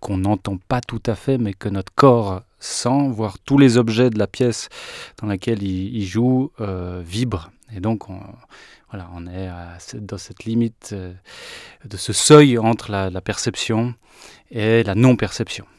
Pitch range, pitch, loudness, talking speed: 95-120 Hz, 110 Hz, -19 LUFS, 165 wpm